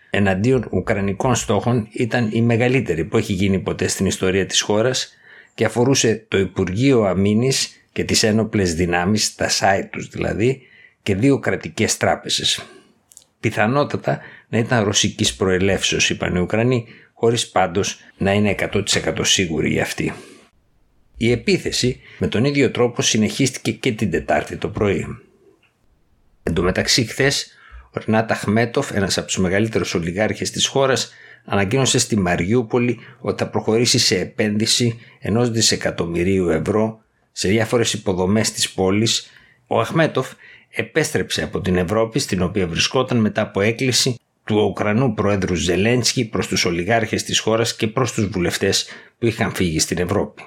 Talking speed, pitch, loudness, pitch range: 135 wpm, 110 Hz, -19 LUFS, 95-120 Hz